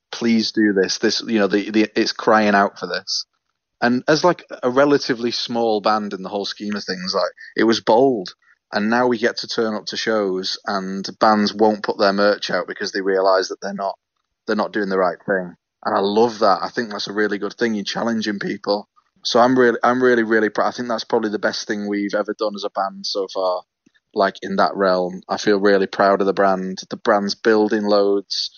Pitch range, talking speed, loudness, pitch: 100-110 Hz, 230 wpm, -19 LUFS, 105 Hz